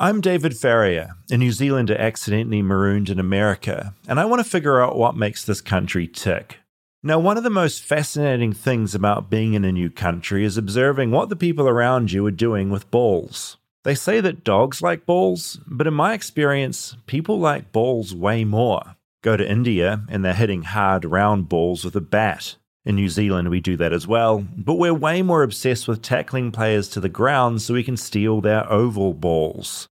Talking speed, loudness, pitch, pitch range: 195 wpm, -20 LUFS, 110 Hz, 100-135 Hz